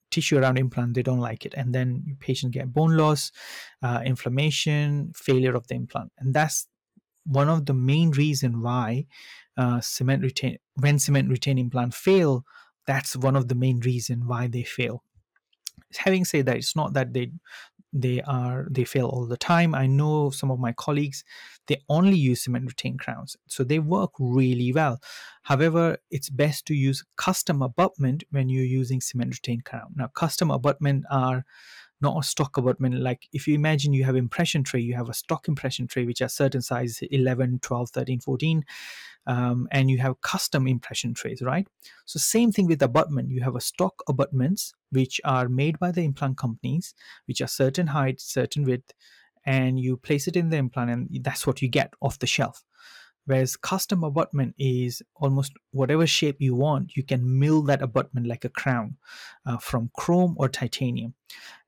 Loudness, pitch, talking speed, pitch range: -25 LUFS, 135 Hz, 180 wpm, 125-150 Hz